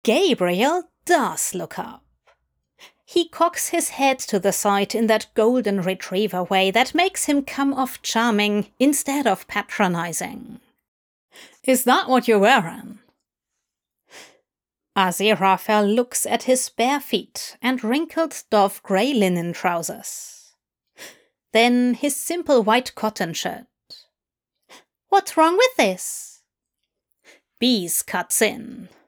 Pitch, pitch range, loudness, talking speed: 235 Hz, 205-275 Hz, -20 LUFS, 115 wpm